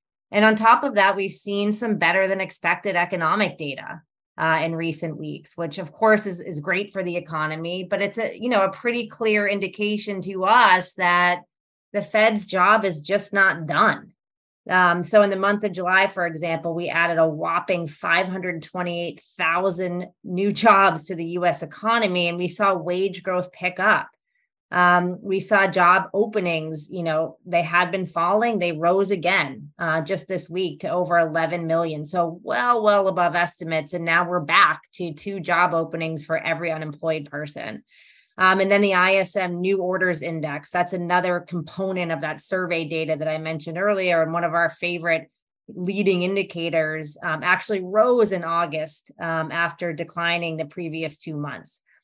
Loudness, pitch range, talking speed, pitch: -21 LUFS, 165-195 Hz, 170 wpm, 180 Hz